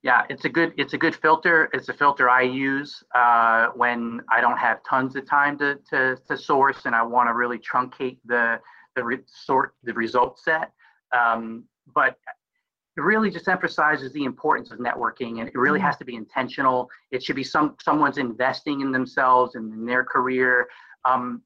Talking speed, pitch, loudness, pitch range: 190 wpm, 130 Hz, -22 LUFS, 120-145 Hz